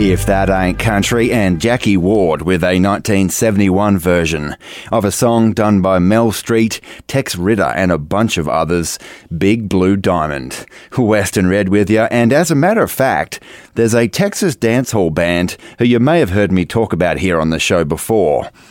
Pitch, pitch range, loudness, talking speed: 100 Hz, 90-115 Hz, -14 LUFS, 185 wpm